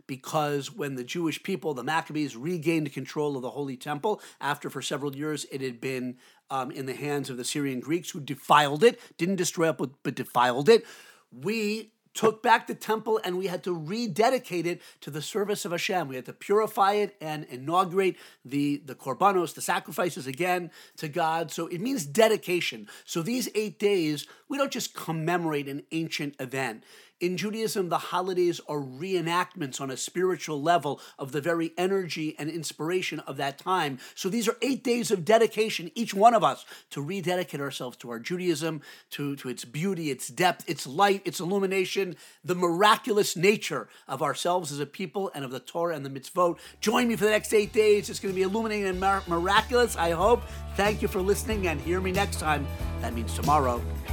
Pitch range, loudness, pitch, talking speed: 145-195 Hz, -27 LUFS, 170 Hz, 190 wpm